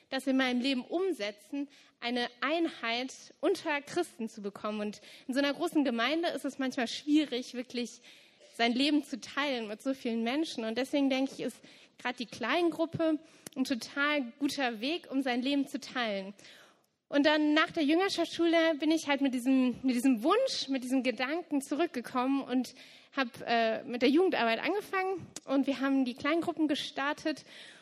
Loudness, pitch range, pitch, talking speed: -31 LUFS, 245-305 Hz, 275 Hz, 170 wpm